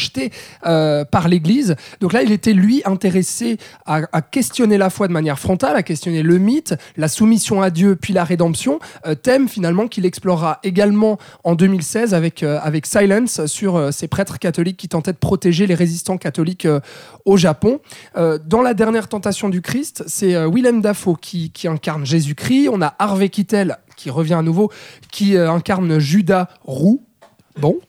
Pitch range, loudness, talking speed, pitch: 165-205 Hz, -17 LUFS, 180 wpm, 185 Hz